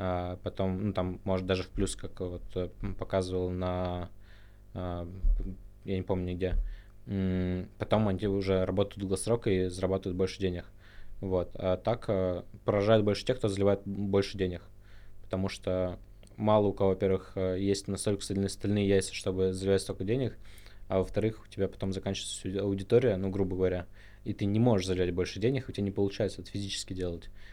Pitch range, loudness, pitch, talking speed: 95-100 Hz, -31 LUFS, 95 Hz, 155 wpm